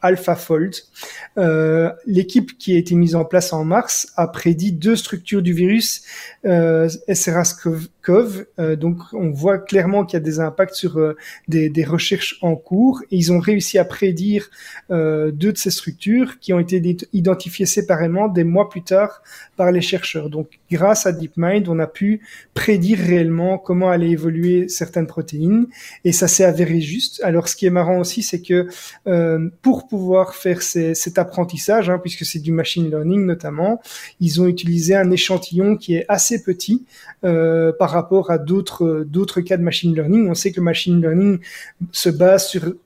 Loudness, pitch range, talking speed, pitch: -18 LUFS, 170-195 Hz, 180 wpm, 180 Hz